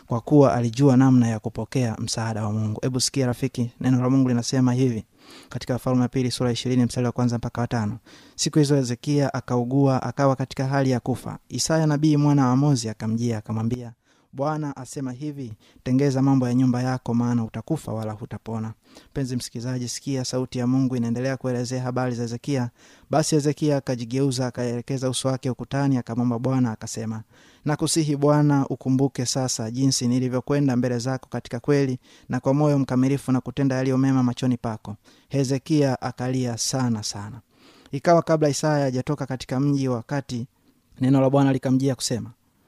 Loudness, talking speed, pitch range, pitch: -23 LUFS, 150 wpm, 120-135 Hz, 130 Hz